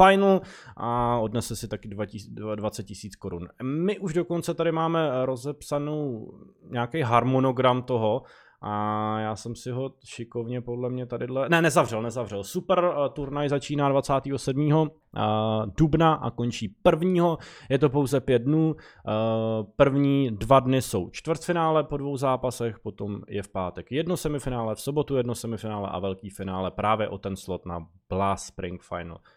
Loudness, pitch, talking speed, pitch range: -26 LUFS, 125 Hz, 150 wpm, 110-145 Hz